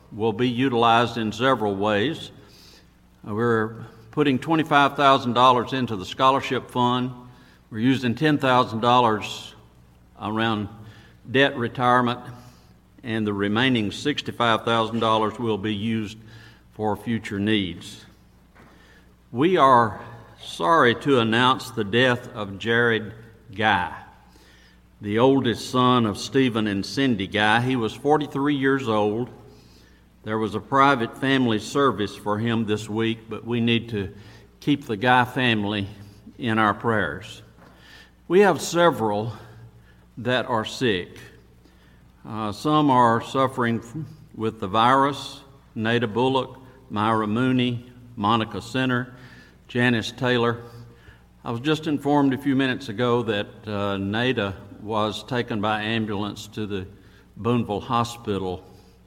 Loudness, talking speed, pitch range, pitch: -22 LUFS, 115 wpm, 105-125 Hz, 115 Hz